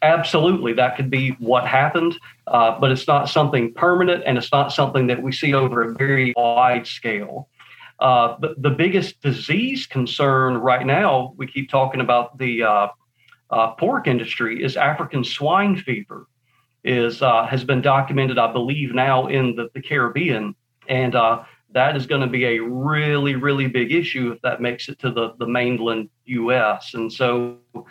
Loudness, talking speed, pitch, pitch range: -19 LUFS, 170 wpm, 130 Hz, 120-140 Hz